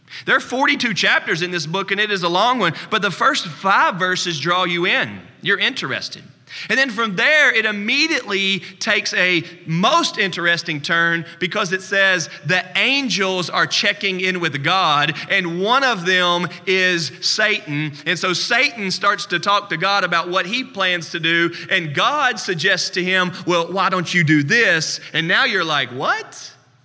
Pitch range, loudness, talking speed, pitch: 175-205 Hz, -17 LUFS, 180 wpm, 185 Hz